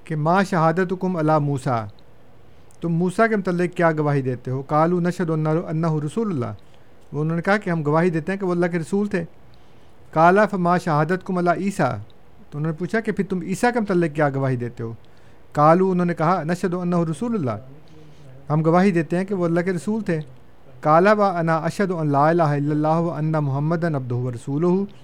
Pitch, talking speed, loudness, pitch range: 165 Hz, 200 wpm, -21 LUFS, 145-180 Hz